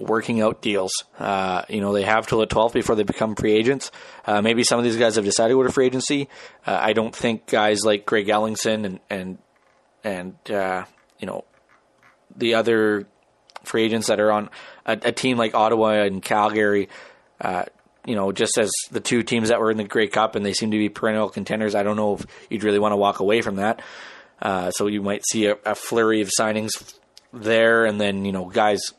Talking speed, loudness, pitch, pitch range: 215 wpm, -21 LUFS, 110 Hz, 105-115 Hz